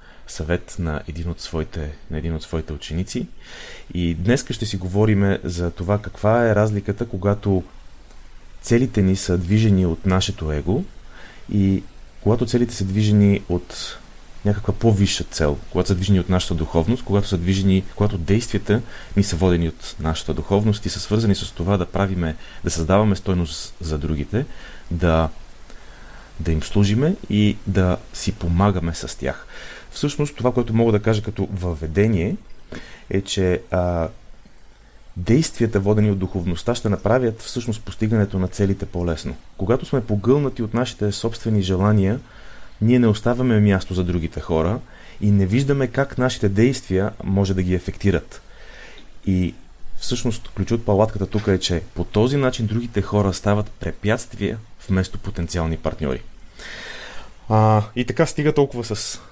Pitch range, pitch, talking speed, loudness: 90-110 Hz, 100 Hz, 150 wpm, -21 LUFS